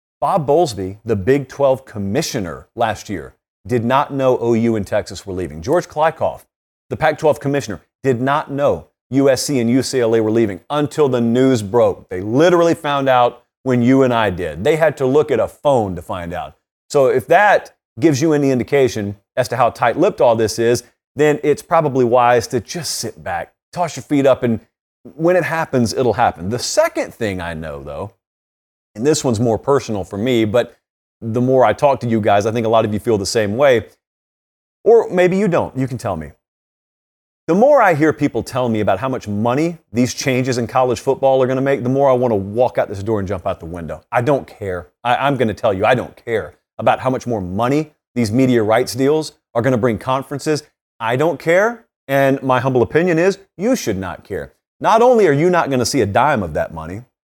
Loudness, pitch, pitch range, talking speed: -17 LUFS, 125 Hz, 110-145 Hz, 215 wpm